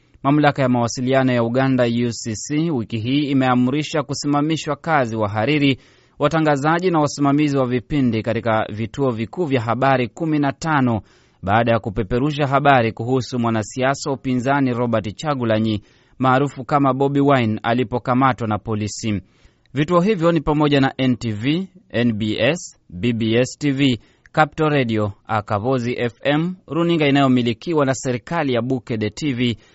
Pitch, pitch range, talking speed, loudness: 130 Hz, 115-145 Hz, 120 wpm, -19 LUFS